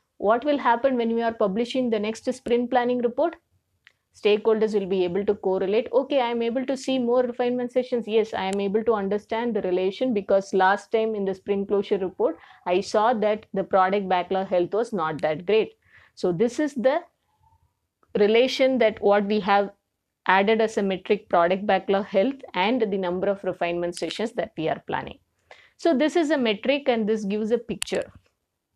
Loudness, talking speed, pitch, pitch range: -24 LUFS, 190 wpm, 215 Hz, 195-245 Hz